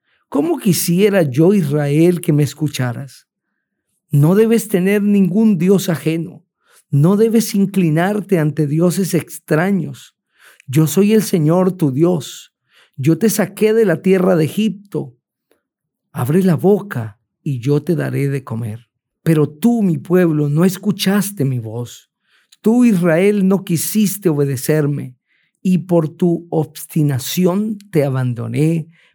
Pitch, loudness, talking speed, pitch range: 170 Hz, -16 LUFS, 125 wpm, 150-195 Hz